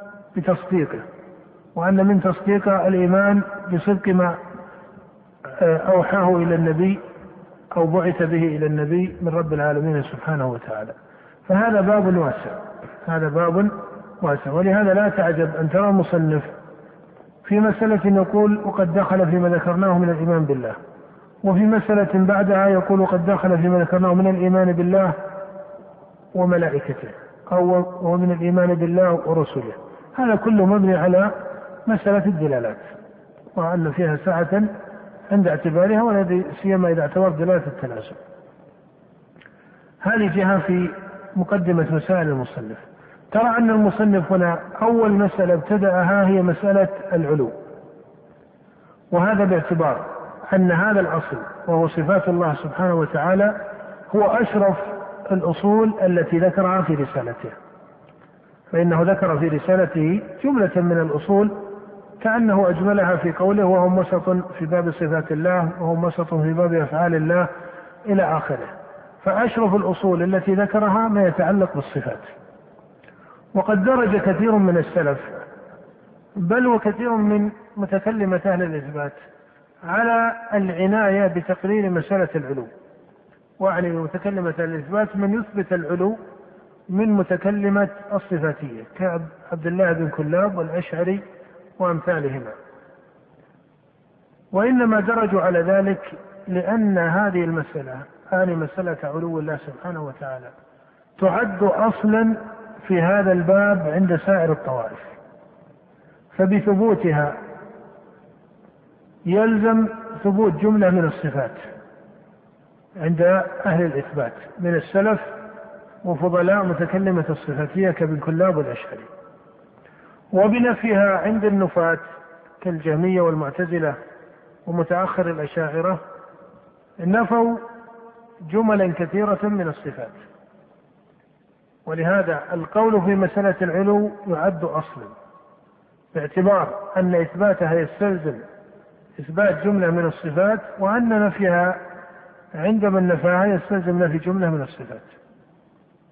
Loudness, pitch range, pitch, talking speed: -20 LUFS, 170-200 Hz, 185 Hz, 100 wpm